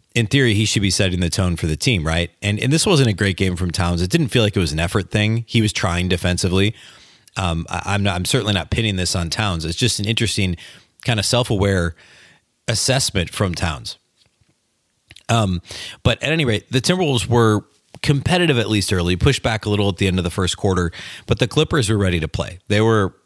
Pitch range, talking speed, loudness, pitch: 90-120 Hz, 225 wpm, -19 LUFS, 105 Hz